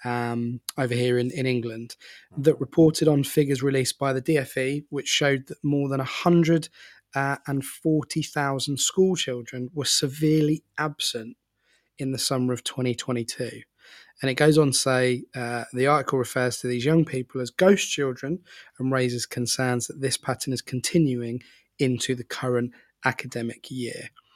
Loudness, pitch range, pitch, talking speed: -25 LUFS, 125-150 Hz, 135 Hz, 150 wpm